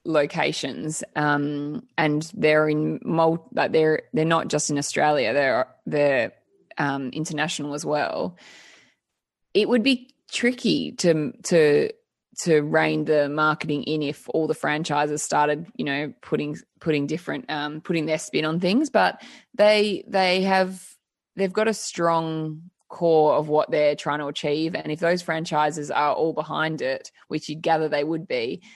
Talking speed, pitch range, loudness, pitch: 155 wpm, 150-185 Hz, -23 LUFS, 155 Hz